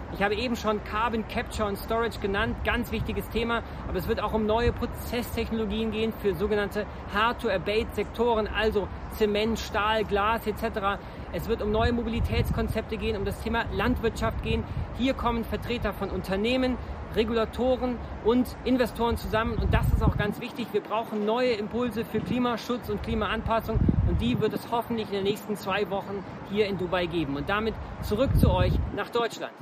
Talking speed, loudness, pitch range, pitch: 170 wpm, -28 LUFS, 205-235 Hz, 220 Hz